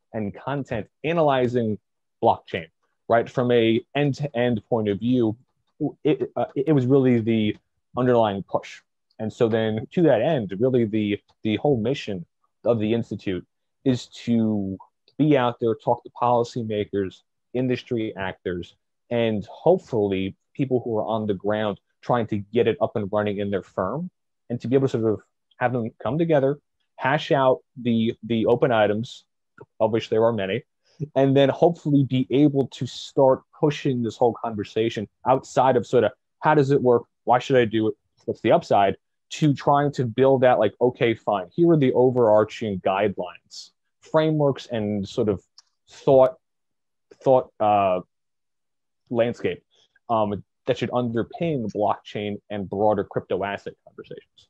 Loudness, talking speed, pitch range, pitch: -23 LUFS, 160 wpm, 105-135 Hz, 120 Hz